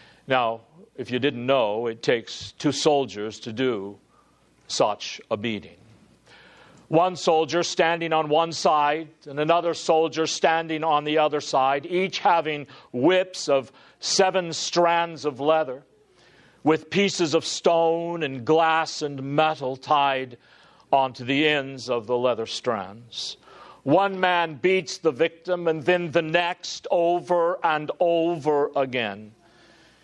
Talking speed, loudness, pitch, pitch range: 130 wpm, -23 LUFS, 155 Hz, 135-170 Hz